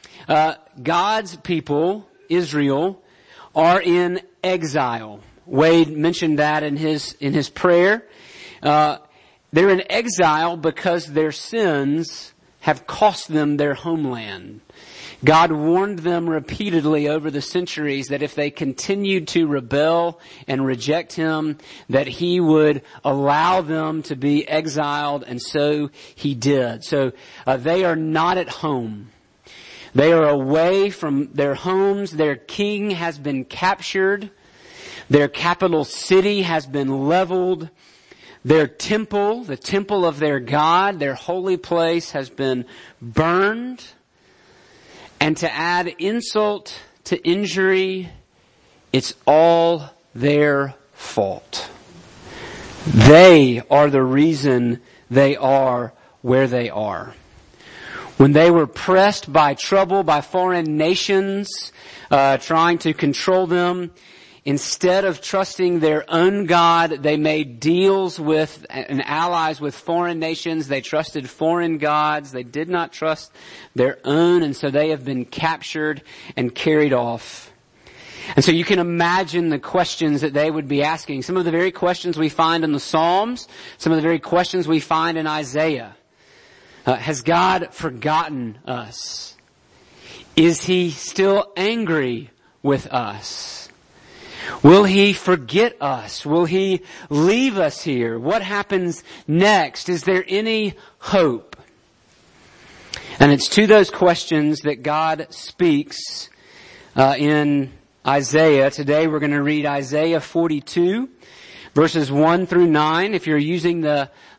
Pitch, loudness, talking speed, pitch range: 160 Hz, -18 LUFS, 125 wpm, 145-180 Hz